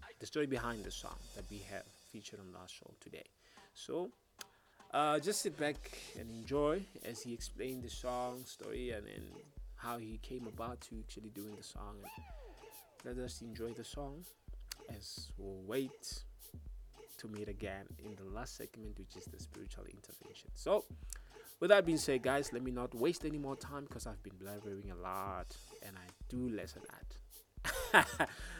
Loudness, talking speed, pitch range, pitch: -40 LUFS, 170 wpm, 100-135 Hz, 115 Hz